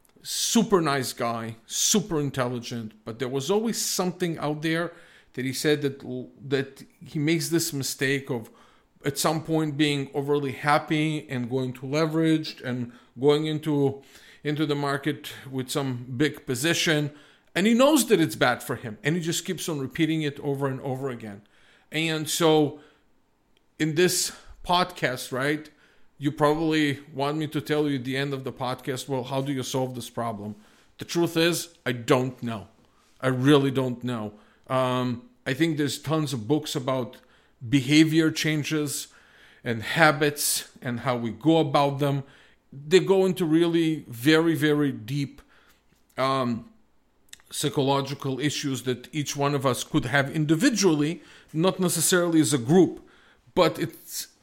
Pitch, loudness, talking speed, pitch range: 145 Hz, -25 LUFS, 155 wpm, 130-160 Hz